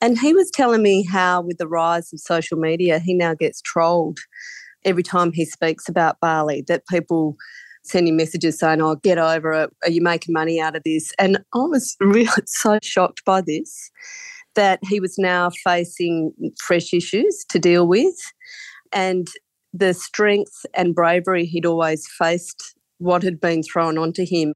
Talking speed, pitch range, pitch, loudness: 175 wpm, 165-195 Hz, 175 Hz, -19 LUFS